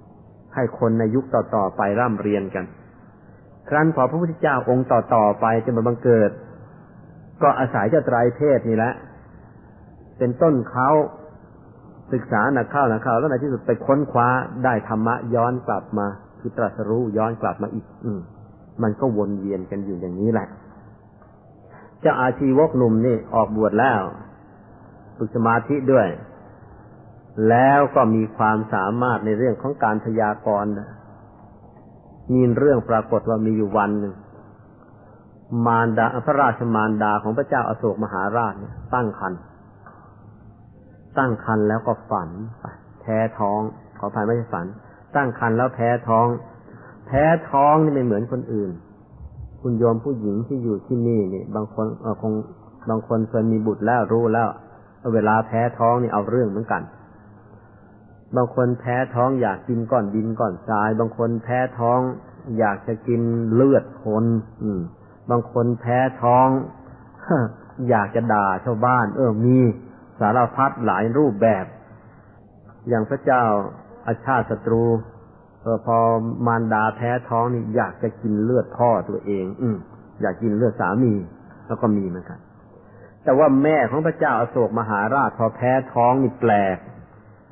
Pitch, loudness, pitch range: 115 Hz, -21 LUFS, 105-125 Hz